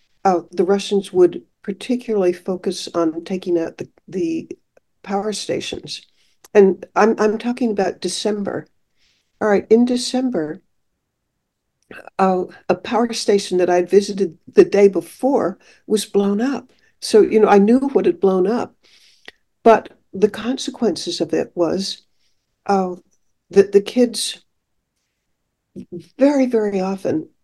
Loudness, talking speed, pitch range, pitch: -18 LUFS, 125 wpm, 190-240 Hz, 200 Hz